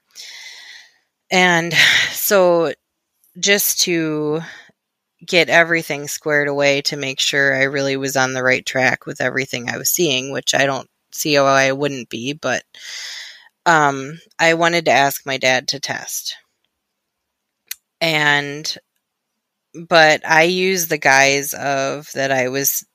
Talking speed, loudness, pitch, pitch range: 135 wpm, -16 LUFS, 150 Hz, 135-170 Hz